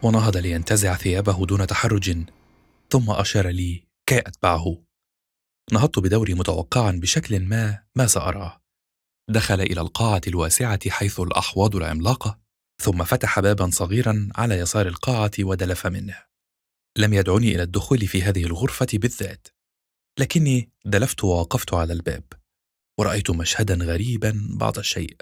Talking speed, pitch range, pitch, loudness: 120 wpm, 90-110 Hz, 100 Hz, -22 LUFS